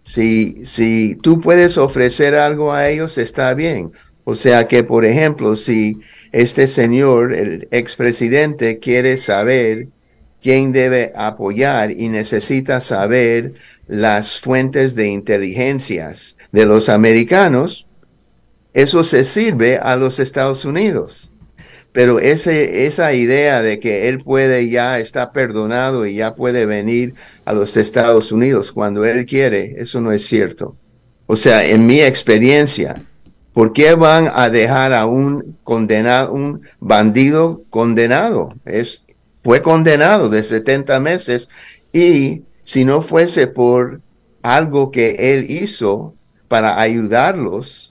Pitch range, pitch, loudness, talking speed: 115-135 Hz, 125 Hz, -13 LUFS, 125 wpm